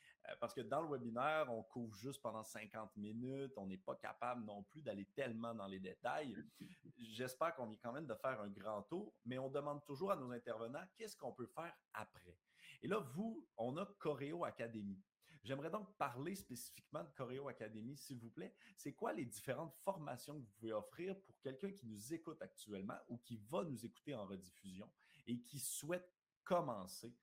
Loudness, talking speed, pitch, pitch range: -48 LUFS, 195 wpm, 125 Hz, 110-150 Hz